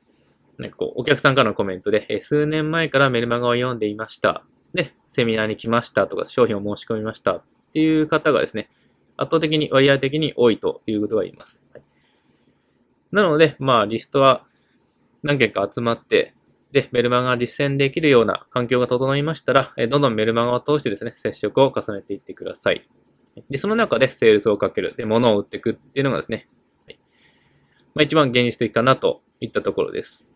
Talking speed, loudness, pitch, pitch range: 395 characters per minute, -20 LUFS, 135 Hz, 115-155 Hz